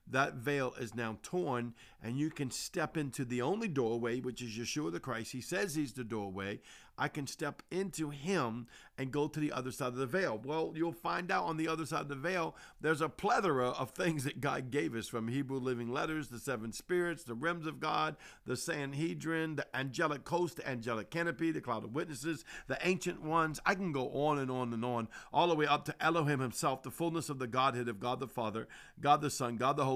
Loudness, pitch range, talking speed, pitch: -36 LUFS, 125-160 Hz, 225 wpm, 145 Hz